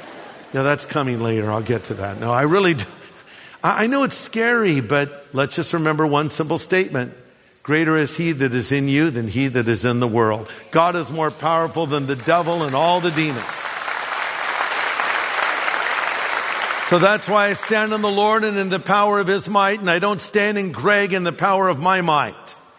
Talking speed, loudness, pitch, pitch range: 195 wpm, -19 LUFS, 165 Hz, 140-195 Hz